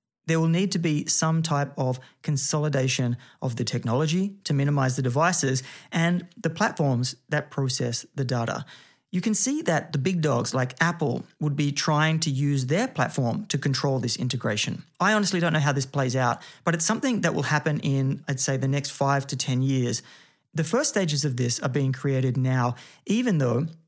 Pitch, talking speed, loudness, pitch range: 145 Hz, 195 wpm, -25 LUFS, 130-165 Hz